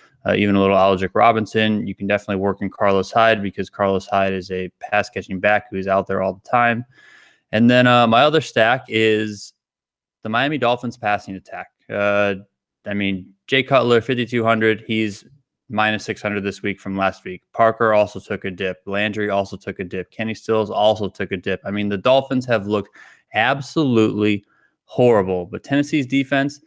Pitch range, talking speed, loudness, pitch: 100-120 Hz, 180 wpm, -19 LUFS, 105 Hz